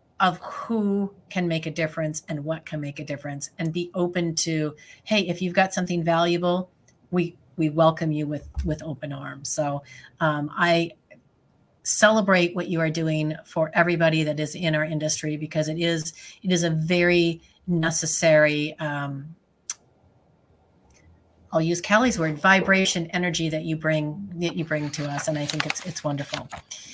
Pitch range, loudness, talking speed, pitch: 150-175 Hz, -24 LUFS, 165 wpm, 160 Hz